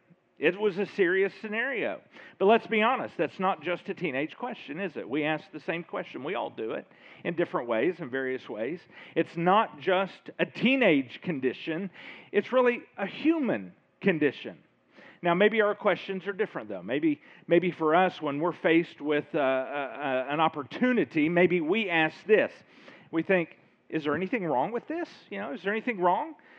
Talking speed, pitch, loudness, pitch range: 185 wpm, 180 Hz, -28 LUFS, 160-215 Hz